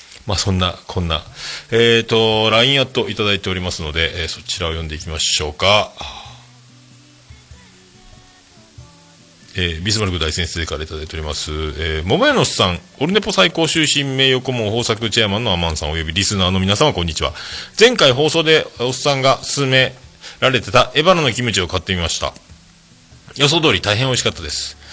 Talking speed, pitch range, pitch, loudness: 385 characters per minute, 85-130 Hz, 105 Hz, -16 LUFS